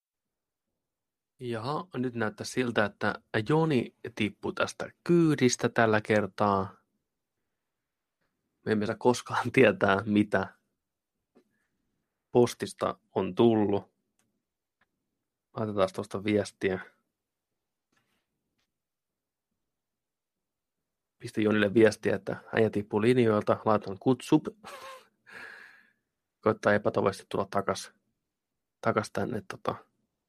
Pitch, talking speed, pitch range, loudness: 110 Hz, 75 wpm, 105-125 Hz, -28 LUFS